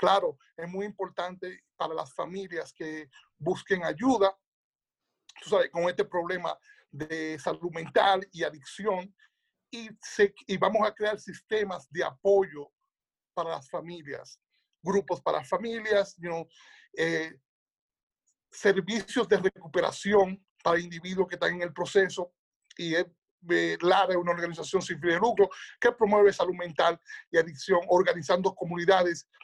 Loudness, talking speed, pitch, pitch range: -28 LUFS, 135 wpm, 185 Hz, 170-200 Hz